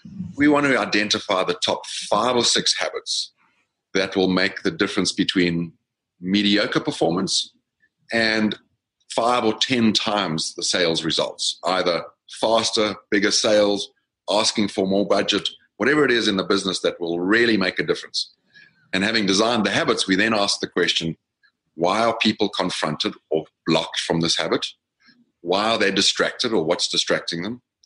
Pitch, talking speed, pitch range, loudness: 105 Hz, 155 wpm, 90-110 Hz, -21 LUFS